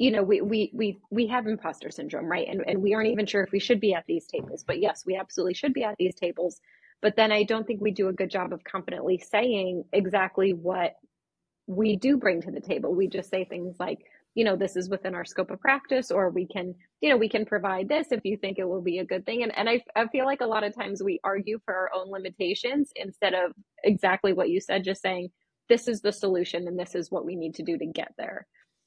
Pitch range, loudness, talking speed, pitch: 185-220 Hz, -27 LUFS, 260 wpm, 195 Hz